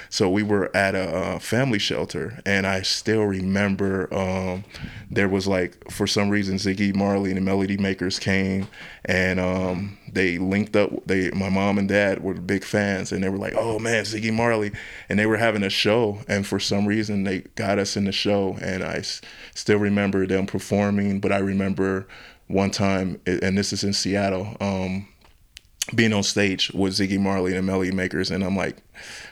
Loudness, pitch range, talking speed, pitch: -23 LUFS, 95-100 Hz, 190 wpm, 95 Hz